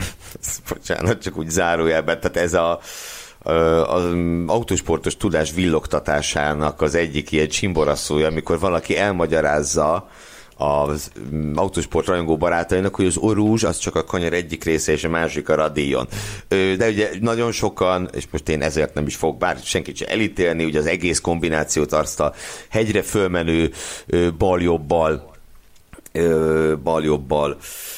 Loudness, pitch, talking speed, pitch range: -20 LUFS, 80 Hz, 130 wpm, 75-90 Hz